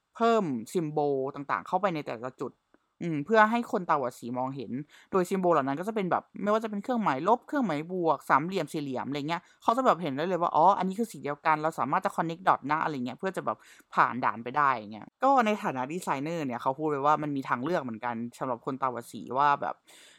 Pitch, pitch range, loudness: 155 Hz, 135-200 Hz, -29 LUFS